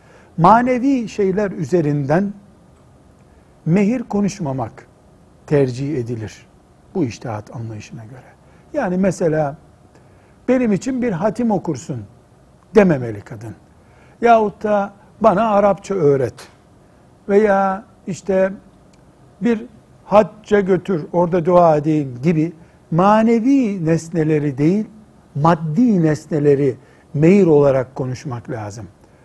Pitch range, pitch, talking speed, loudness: 140-205 Hz, 170 Hz, 90 wpm, -17 LUFS